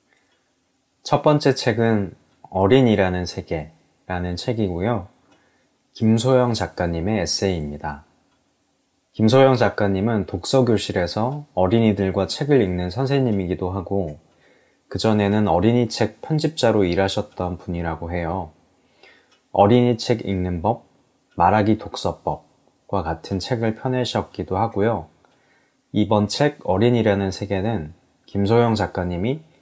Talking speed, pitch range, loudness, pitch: 255 characters per minute, 90-120 Hz, -21 LUFS, 100 Hz